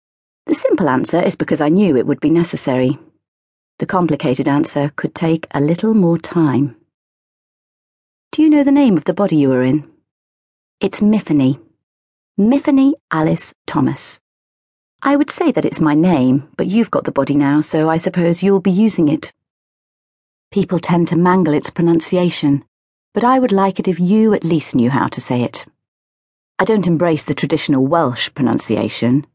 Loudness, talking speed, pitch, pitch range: -15 LUFS, 170 wpm, 165 Hz, 140-195 Hz